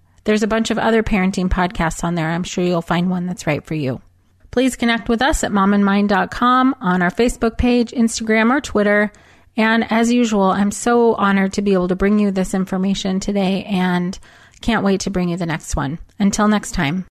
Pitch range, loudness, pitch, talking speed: 180-225 Hz, -17 LUFS, 200 Hz, 205 wpm